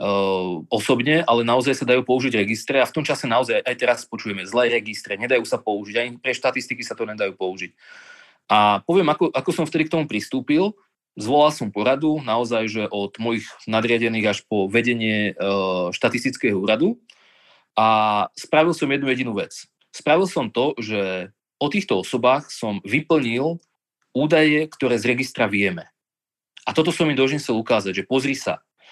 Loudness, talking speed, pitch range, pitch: -21 LUFS, 165 wpm, 105-145 Hz, 120 Hz